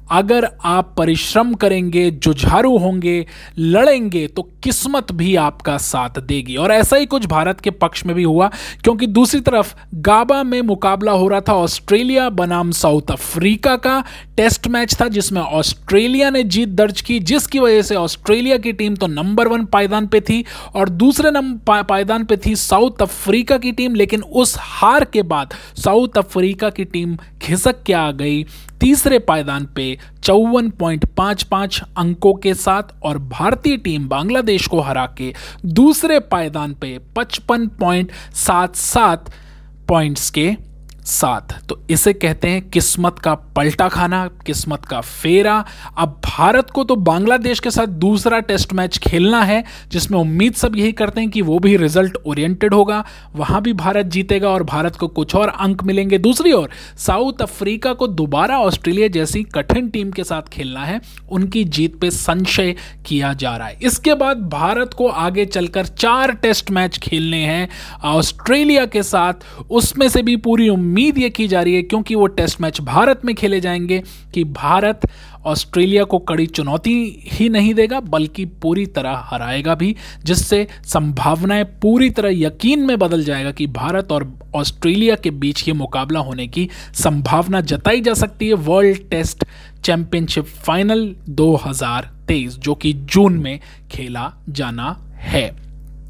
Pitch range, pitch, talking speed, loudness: 160-220 Hz, 190 Hz, 160 wpm, -16 LUFS